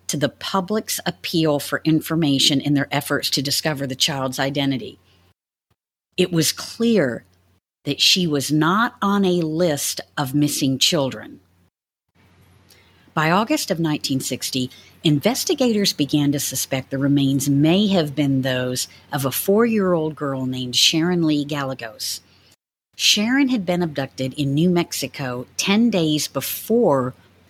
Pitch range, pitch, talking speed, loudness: 130-175 Hz, 145 Hz, 130 wpm, -20 LUFS